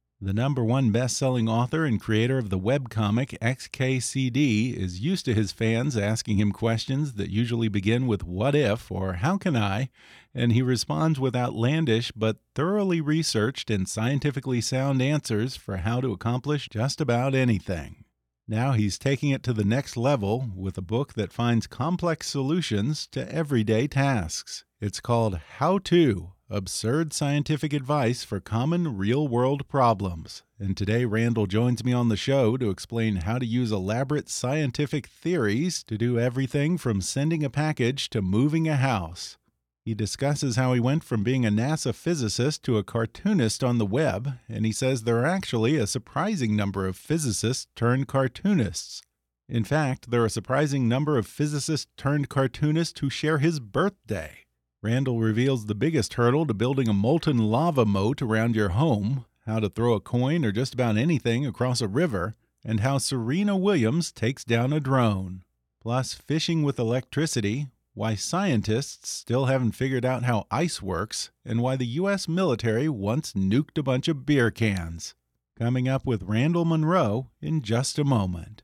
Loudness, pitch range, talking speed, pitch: -26 LUFS, 110-145 Hz, 165 wpm, 125 Hz